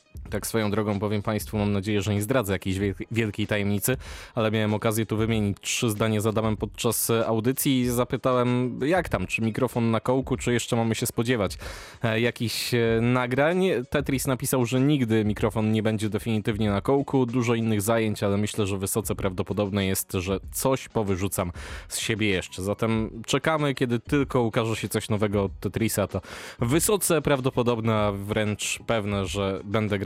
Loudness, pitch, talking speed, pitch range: -25 LUFS, 110 Hz, 165 wpm, 105-125 Hz